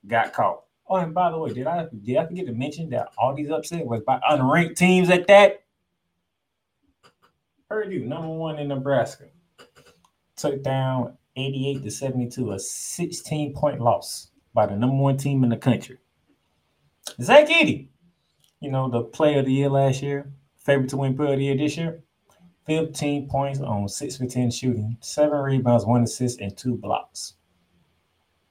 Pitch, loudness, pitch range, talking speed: 135 Hz, -23 LUFS, 120-155 Hz, 170 wpm